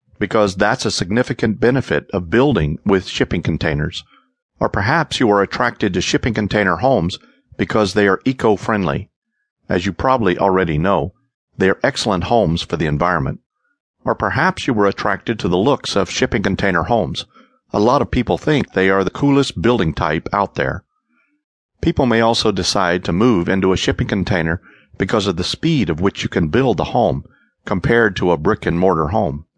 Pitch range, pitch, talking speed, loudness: 90-115 Hz, 100 Hz, 175 wpm, -17 LUFS